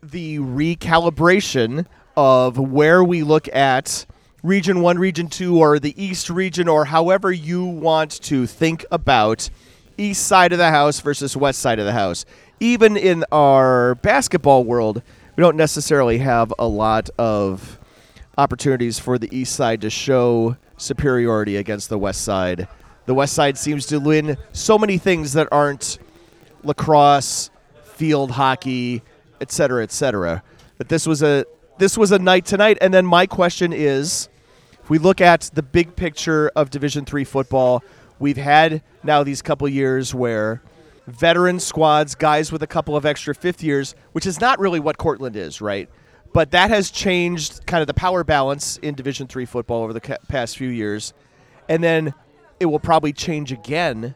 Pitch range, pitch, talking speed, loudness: 130-170 Hz, 150 Hz, 165 wpm, -18 LUFS